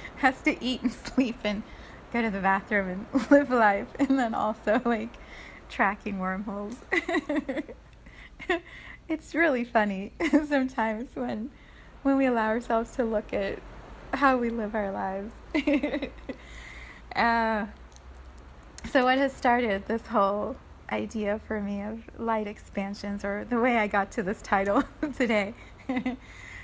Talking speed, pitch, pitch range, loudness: 130 wpm, 230 Hz, 205-260 Hz, -28 LUFS